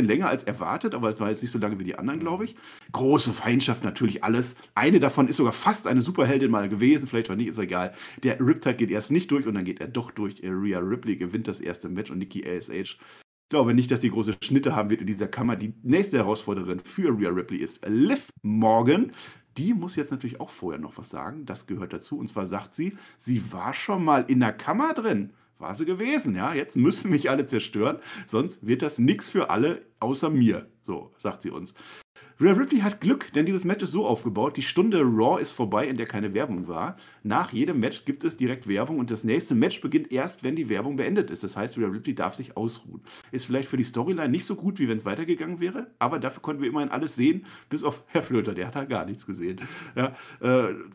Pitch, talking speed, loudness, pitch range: 125 Hz, 235 wpm, -26 LUFS, 110-160 Hz